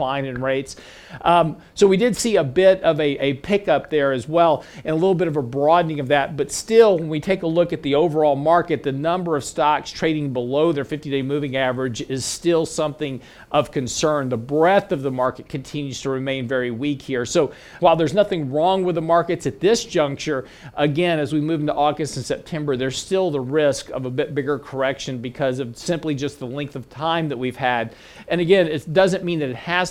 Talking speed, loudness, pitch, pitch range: 220 wpm, -20 LUFS, 150 Hz, 135-170 Hz